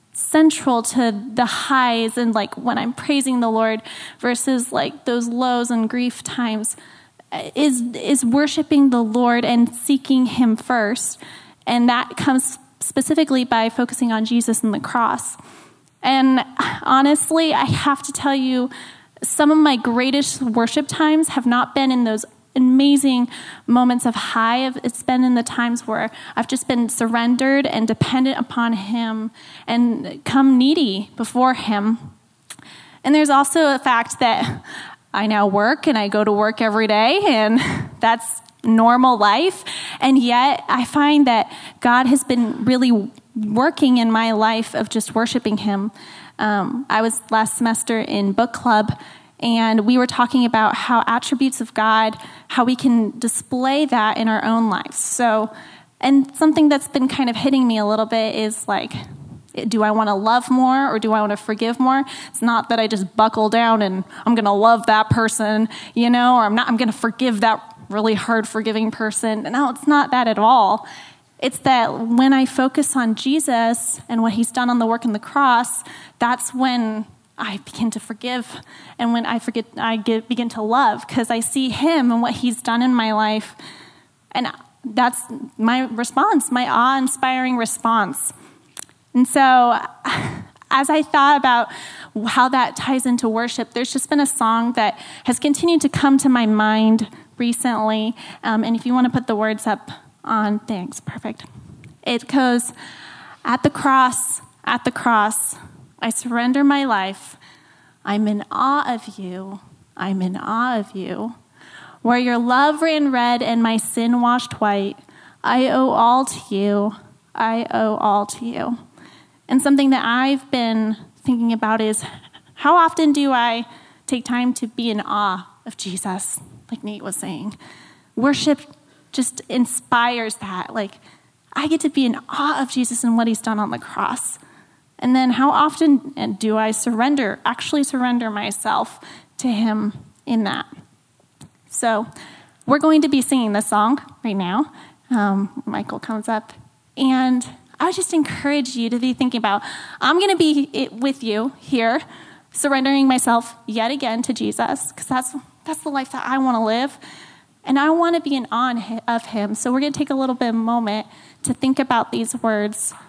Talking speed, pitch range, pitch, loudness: 170 wpm, 225-265 Hz, 240 Hz, -18 LUFS